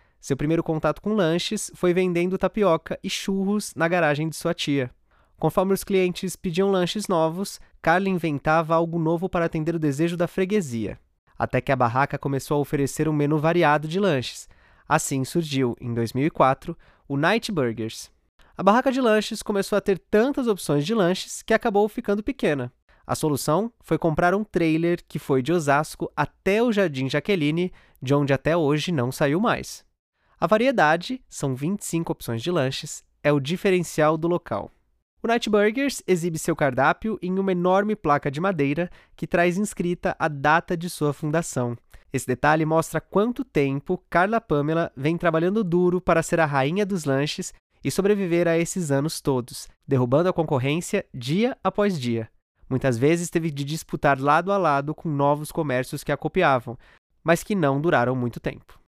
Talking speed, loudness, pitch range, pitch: 170 wpm, -23 LUFS, 145-190 Hz, 165 Hz